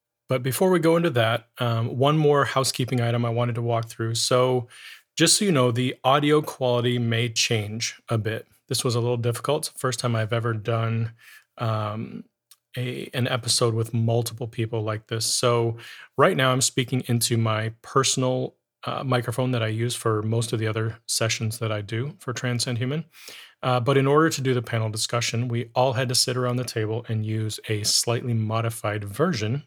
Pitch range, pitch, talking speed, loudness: 115-130 Hz, 120 Hz, 190 wpm, -24 LUFS